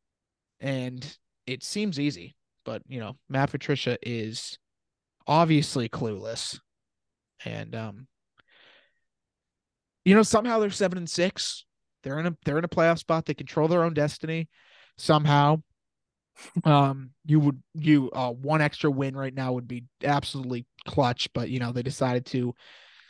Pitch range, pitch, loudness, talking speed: 125-160 Hz, 145 Hz, -26 LUFS, 145 wpm